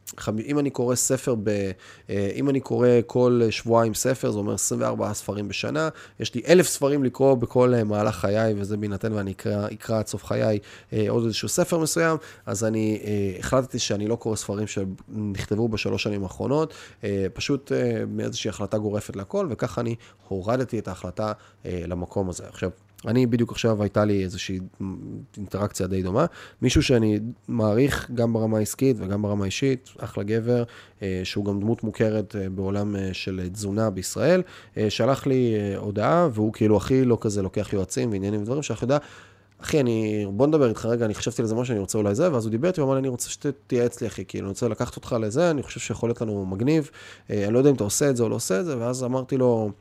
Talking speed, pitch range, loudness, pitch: 185 wpm, 100-125 Hz, -25 LUFS, 110 Hz